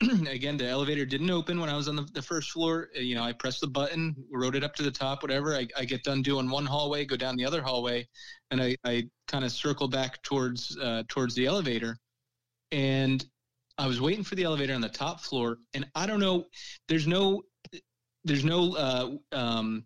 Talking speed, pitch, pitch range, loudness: 215 wpm, 140 Hz, 125-155 Hz, -30 LUFS